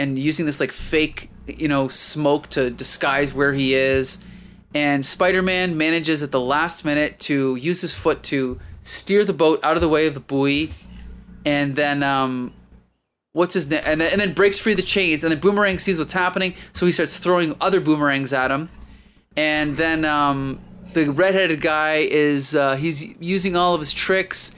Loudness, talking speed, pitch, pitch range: -19 LUFS, 185 wpm, 155 Hz, 140-180 Hz